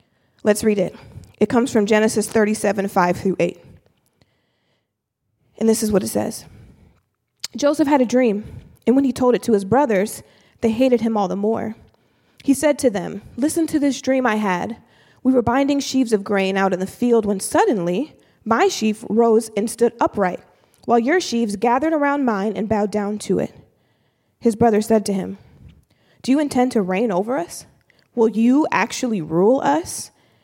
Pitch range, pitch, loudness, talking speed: 200-255 Hz, 225 Hz, -19 LUFS, 180 wpm